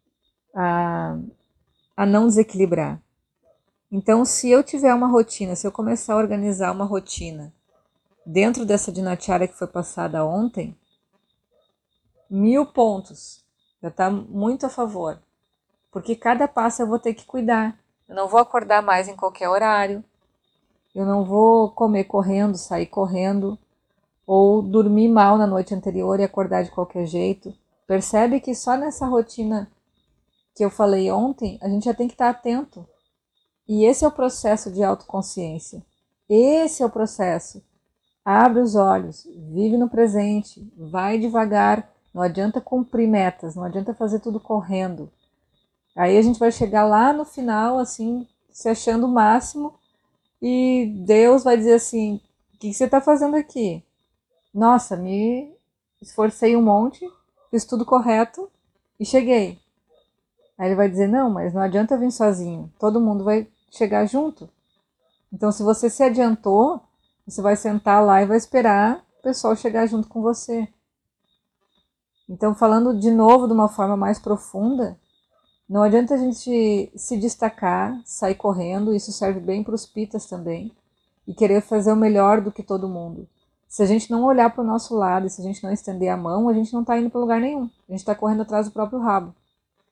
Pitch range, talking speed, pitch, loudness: 195-235 Hz, 160 wpm, 215 Hz, -20 LUFS